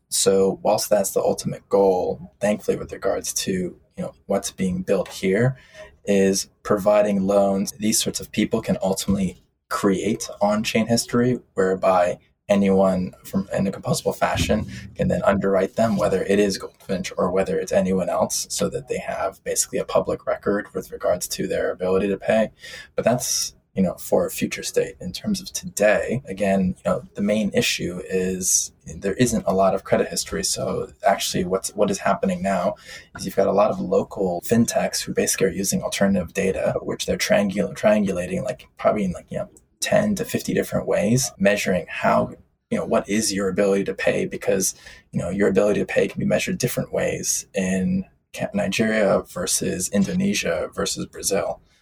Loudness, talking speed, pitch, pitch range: -22 LUFS, 175 wpm, 100 Hz, 95-130 Hz